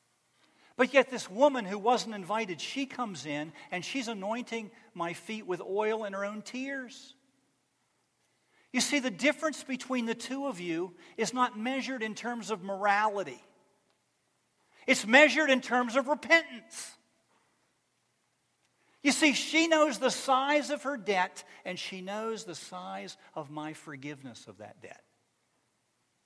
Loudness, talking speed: -30 LUFS, 145 wpm